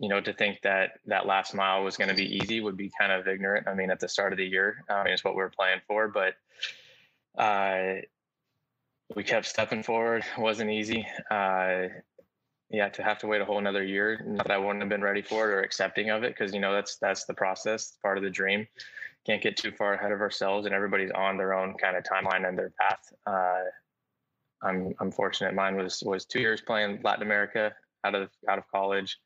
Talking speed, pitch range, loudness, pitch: 230 wpm, 95-105 Hz, -29 LUFS, 100 Hz